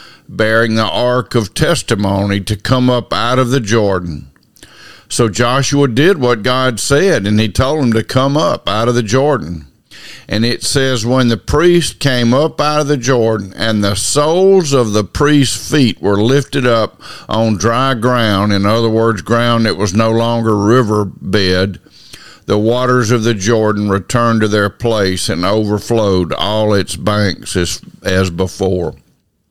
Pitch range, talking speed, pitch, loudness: 105-125 Hz, 165 wpm, 115 Hz, -13 LUFS